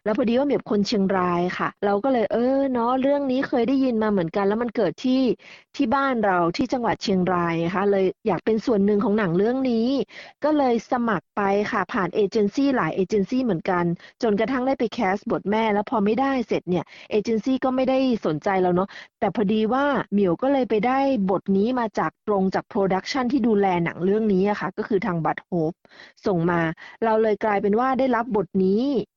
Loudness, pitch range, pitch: -22 LUFS, 195-250 Hz, 215 Hz